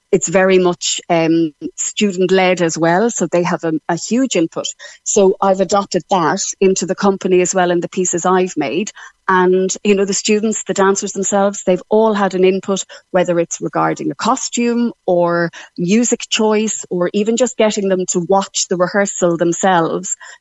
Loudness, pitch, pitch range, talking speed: -15 LUFS, 190 Hz, 180-205 Hz, 175 wpm